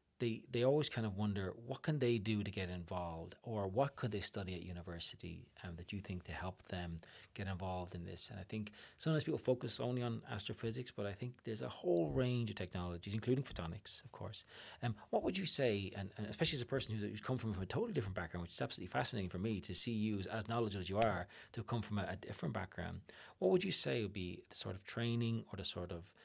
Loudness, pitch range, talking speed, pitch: -40 LUFS, 95-120 Hz, 250 wpm, 105 Hz